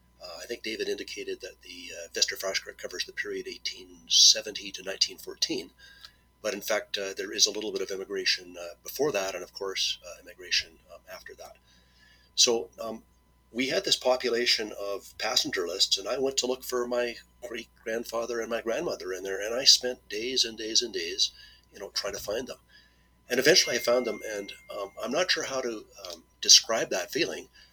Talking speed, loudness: 195 wpm, -26 LUFS